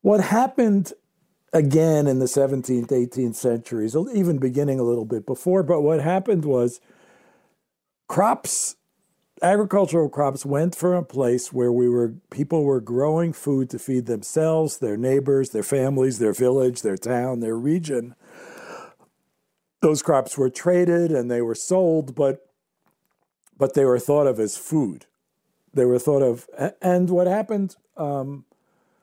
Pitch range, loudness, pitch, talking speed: 125-175 Hz, -22 LUFS, 140 Hz, 145 wpm